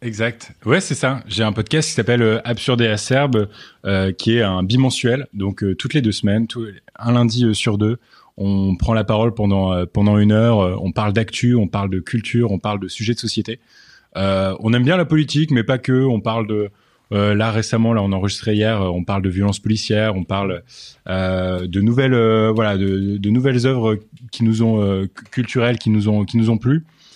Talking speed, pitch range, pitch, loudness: 215 wpm, 100-120 Hz, 110 Hz, -18 LUFS